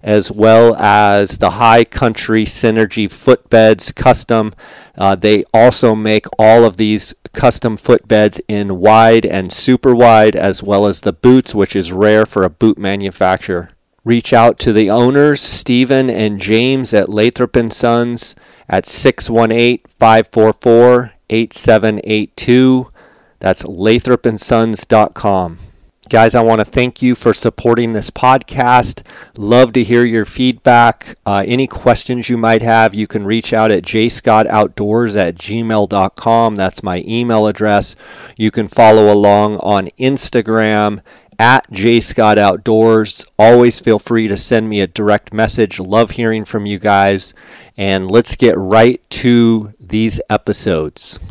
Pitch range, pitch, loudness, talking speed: 105-120 Hz, 110 Hz, -11 LUFS, 130 wpm